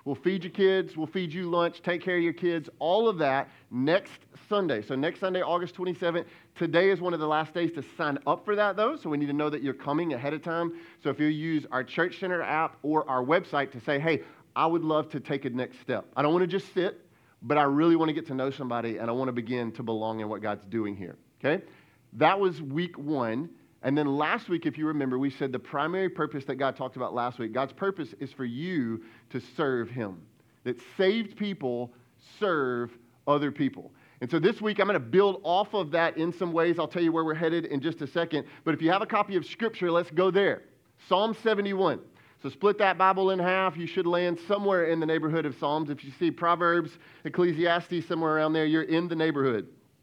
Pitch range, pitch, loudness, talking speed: 140-180 Hz, 160 Hz, -28 LUFS, 235 wpm